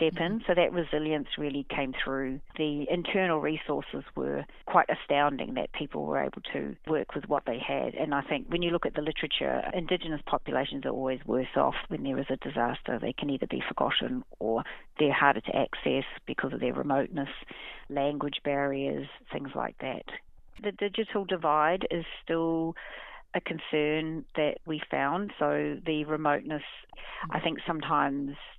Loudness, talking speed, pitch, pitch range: -30 LUFS, 165 wpm, 150 Hz, 140-170 Hz